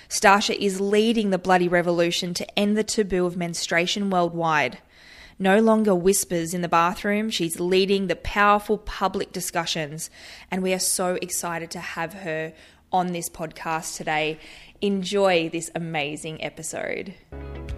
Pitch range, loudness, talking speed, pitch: 165-195 Hz, -23 LUFS, 140 wpm, 180 Hz